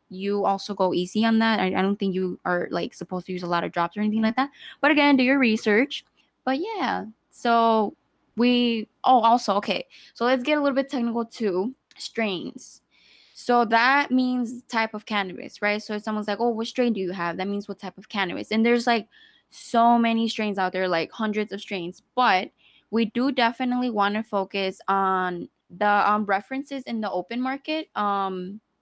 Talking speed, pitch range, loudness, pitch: 200 wpm, 195-245 Hz, -24 LUFS, 220 Hz